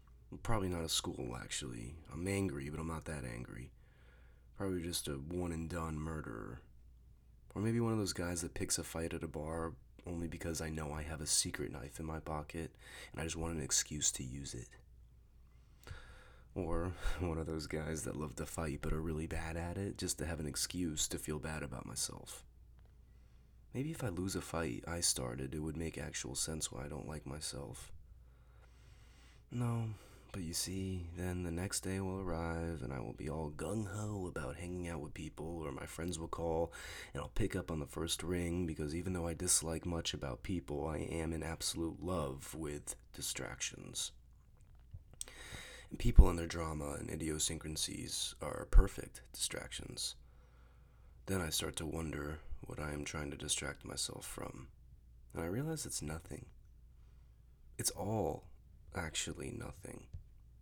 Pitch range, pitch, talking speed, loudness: 70-85 Hz, 80 Hz, 175 wpm, -40 LUFS